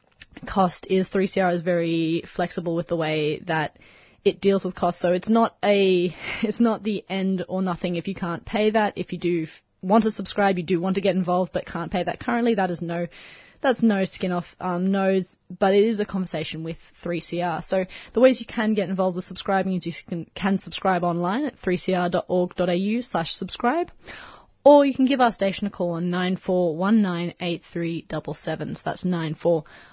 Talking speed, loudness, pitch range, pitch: 190 wpm, -23 LUFS, 175-200 Hz, 185 Hz